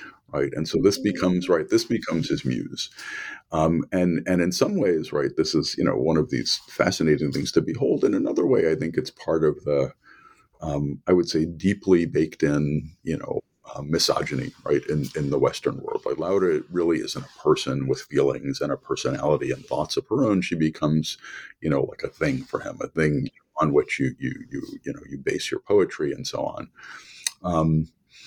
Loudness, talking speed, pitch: -24 LUFS, 205 wpm, 90 Hz